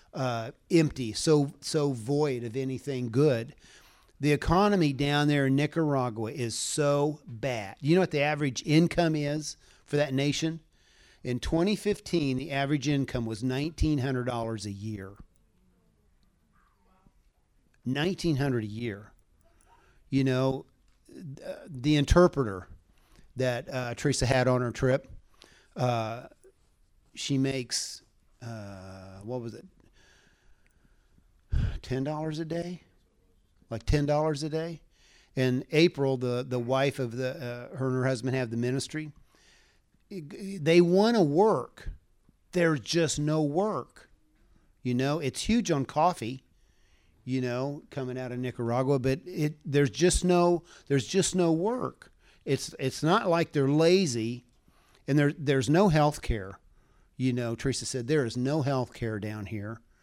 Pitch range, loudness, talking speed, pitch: 120-155 Hz, -28 LUFS, 135 wpm, 135 Hz